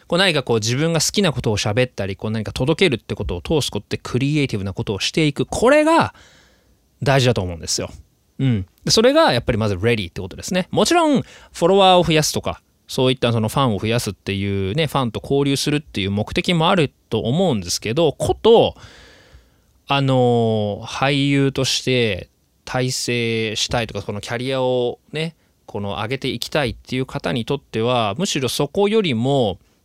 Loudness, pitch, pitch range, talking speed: -19 LUFS, 125 Hz, 110-145 Hz, 400 characters per minute